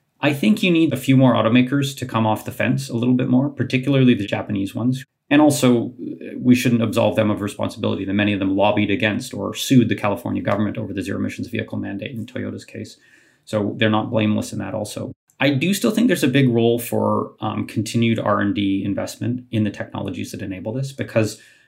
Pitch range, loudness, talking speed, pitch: 105-125 Hz, -20 LUFS, 210 wpm, 110 Hz